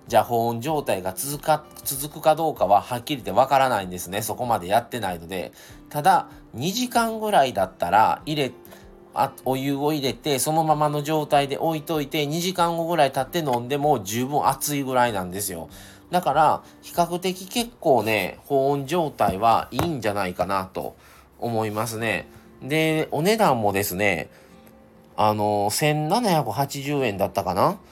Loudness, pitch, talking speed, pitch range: -23 LUFS, 140 Hz, 315 characters per minute, 105-155 Hz